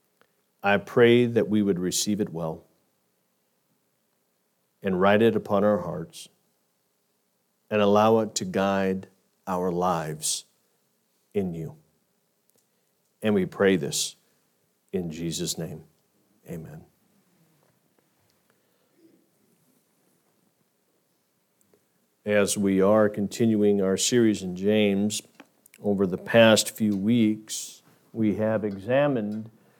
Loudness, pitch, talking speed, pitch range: -24 LUFS, 105 Hz, 95 wpm, 95-110 Hz